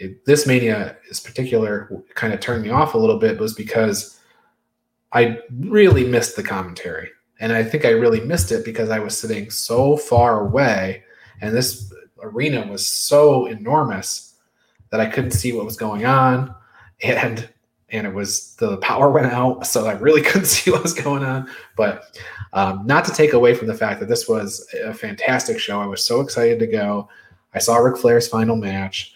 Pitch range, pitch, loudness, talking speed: 105-140 Hz, 115 Hz, -18 LUFS, 195 wpm